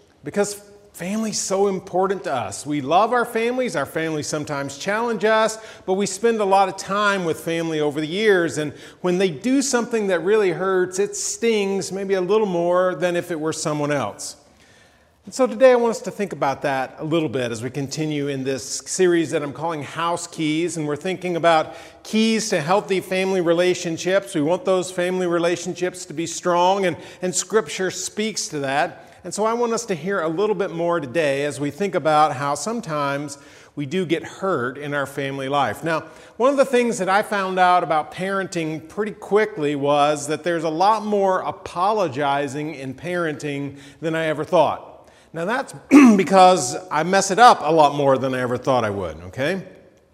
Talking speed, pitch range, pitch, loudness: 195 wpm, 150-195 Hz, 175 Hz, -21 LUFS